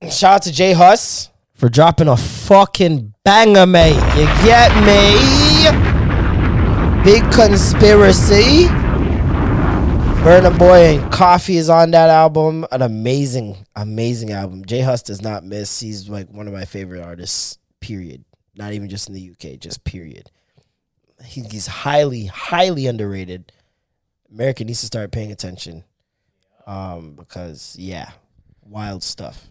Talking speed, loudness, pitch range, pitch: 130 wpm, -11 LUFS, 95-155 Hz, 110 Hz